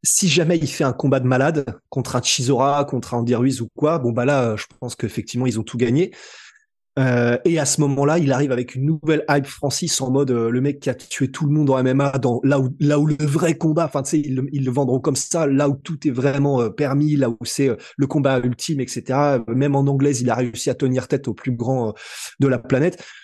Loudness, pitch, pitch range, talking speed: -20 LUFS, 140 Hz, 125-150 Hz, 255 wpm